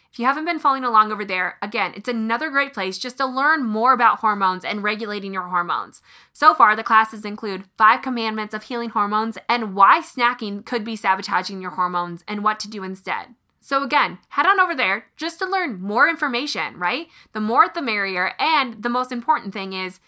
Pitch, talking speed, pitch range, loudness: 220 Hz, 205 wpm, 200-270 Hz, -20 LUFS